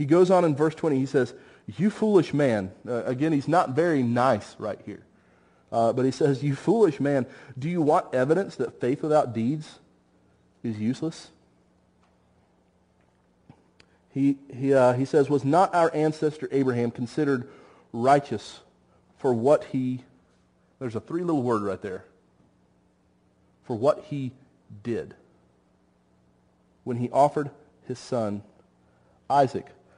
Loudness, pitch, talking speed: -25 LUFS, 125 Hz, 135 wpm